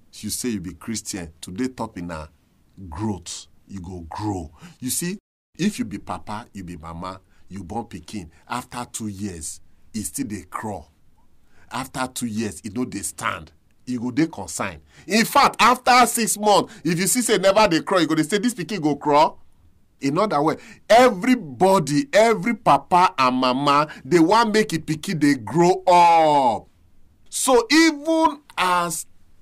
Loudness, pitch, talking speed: -20 LUFS, 130 Hz, 170 wpm